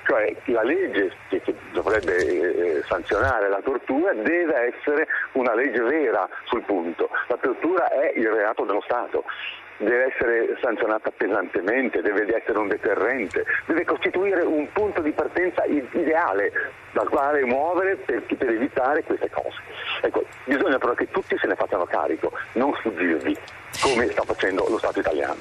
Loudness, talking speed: -23 LUFS, 150 wpm